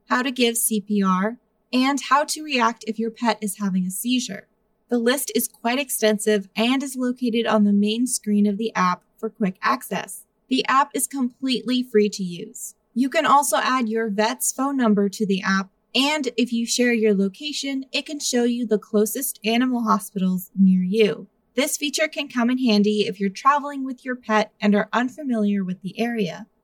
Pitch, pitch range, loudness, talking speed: 225 Hz, 210-250 Hz, -22 LUFS, 190 wpm